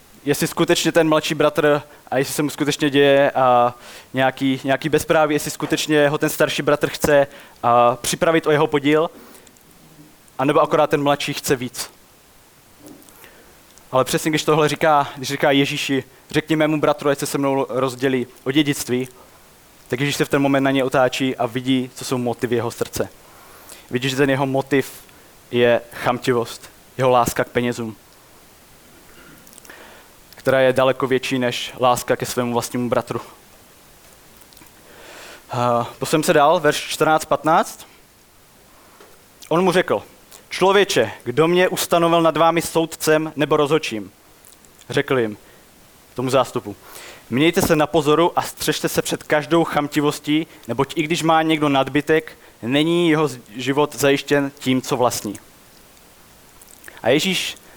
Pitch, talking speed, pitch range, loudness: 140 Hz, 140 wpm, 125-155 Hz, -19 LUFS